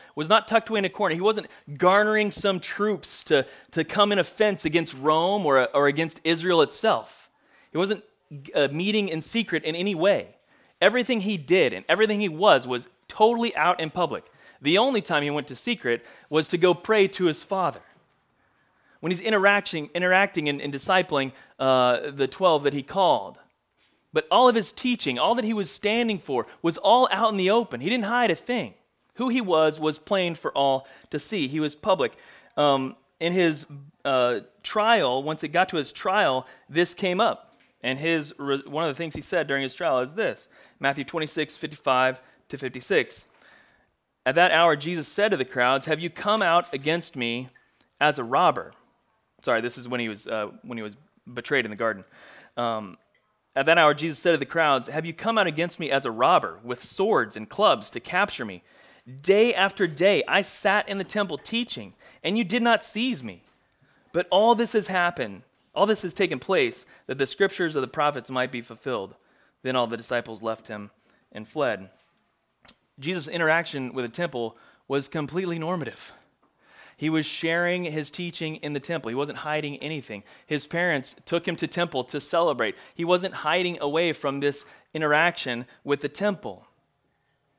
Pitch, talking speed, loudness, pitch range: 165 Hz, 190 wpm, -24 LUFS, 140-195 Hz